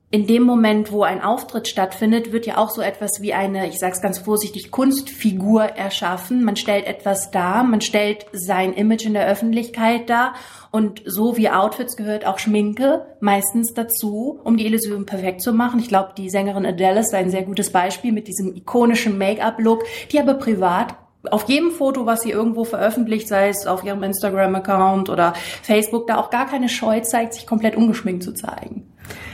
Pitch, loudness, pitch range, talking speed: 215 Hz, -19 LUFS, 195-230 Hz, 185 wpm